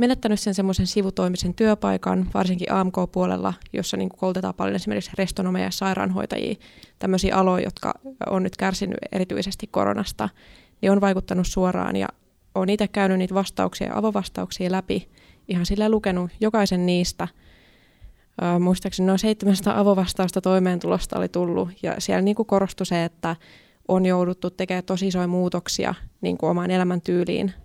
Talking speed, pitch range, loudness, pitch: 140 wpm, 180-195 Hz, -23 LUFS, 185 Hz